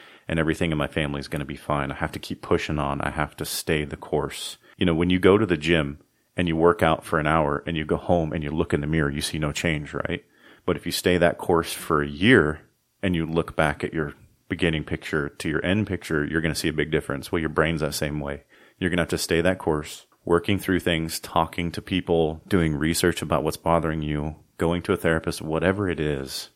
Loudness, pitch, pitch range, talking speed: -24 LUFS, 80 Hz, 75-85 Hz, 255 wpm